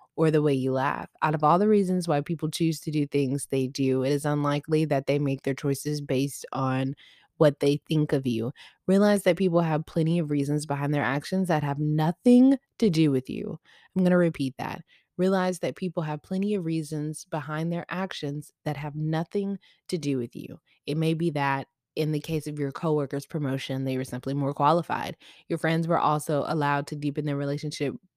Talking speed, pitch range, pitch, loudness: 205 wpm, 140-170 Hz, 150 Hz, -26 LUFS